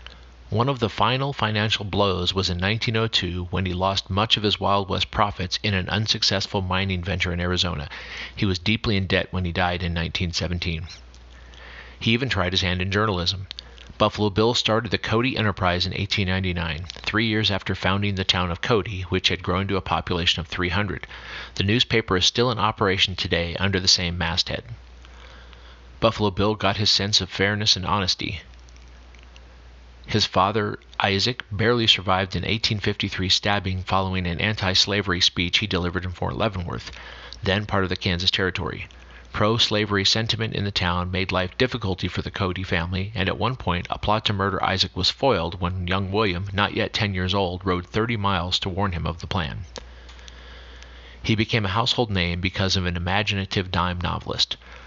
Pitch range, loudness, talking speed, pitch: 90-105 Hz, -23 LUFS, 175 wpm, 95 Hz